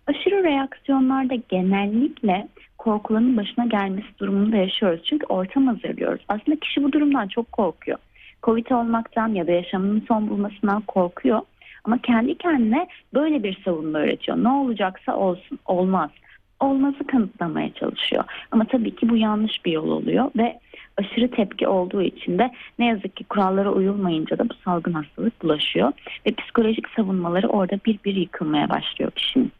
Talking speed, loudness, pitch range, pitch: 145 wpm, -22 LUFS, 190-255 Hz, 220 Hz